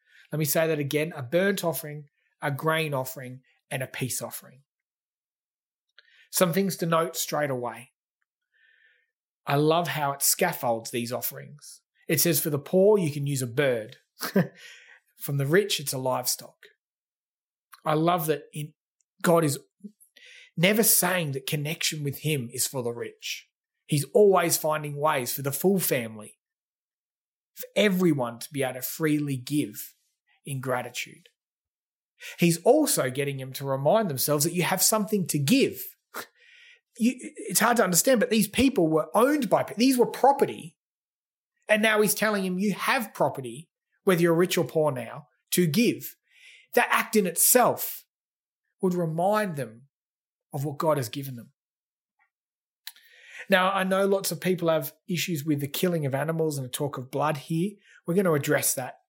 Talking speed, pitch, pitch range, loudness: 160 wpm, 160 Hz, 140-195 Hz, -25 LUFS